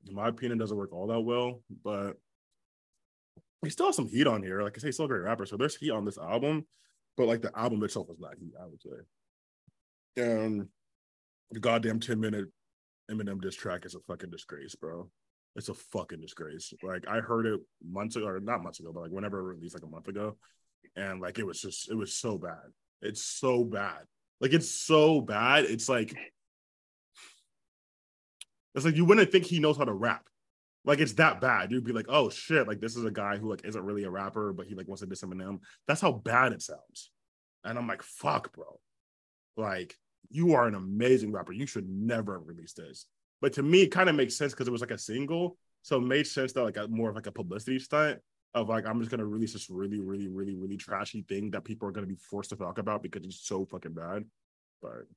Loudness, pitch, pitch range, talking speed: -31 LUFS, 105 Hz, 95-125 Hz, 230 wpm